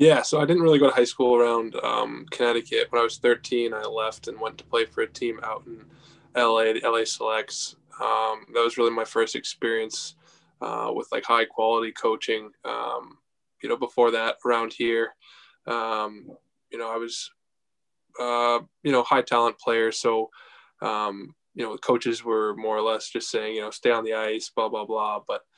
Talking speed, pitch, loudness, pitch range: 195 wpm, 115 Hz, -25 LUFS, 110-120 Hz